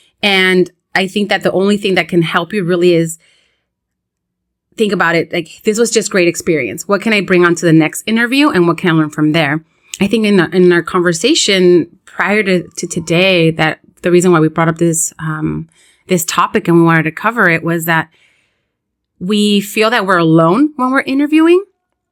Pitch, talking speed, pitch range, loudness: 180 Hz, 205 wpm, 170-205 Hz, -12 LUFS